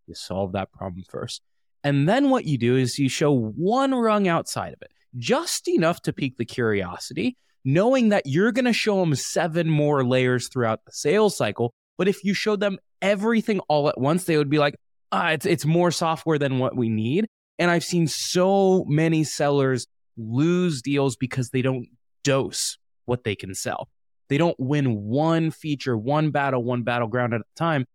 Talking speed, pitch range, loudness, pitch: 190 wpm, 125-175 Hz, -23 LUFS, 145 Hz